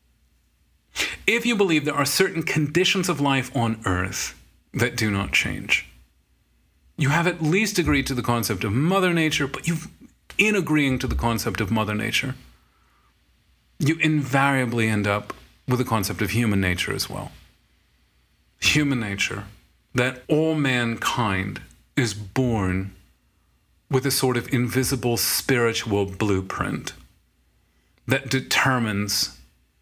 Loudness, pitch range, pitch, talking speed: -23 LUFS, 100-140 Hz, 120 Hz, 125 wpm